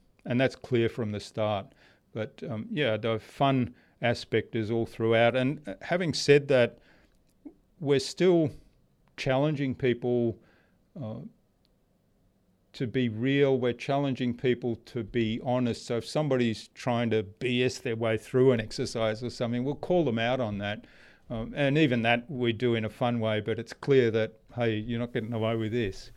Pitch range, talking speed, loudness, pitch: 115-130 Hz, 165 wpm, -28 LUFS, 120 Hz